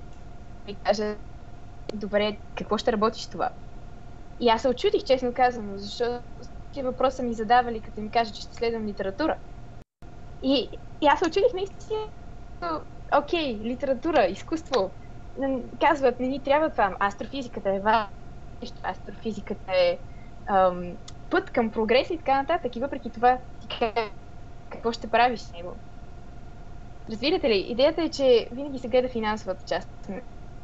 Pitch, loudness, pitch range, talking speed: 245 Hz, -26 LUFS, 215-275 Hz, 135 wpm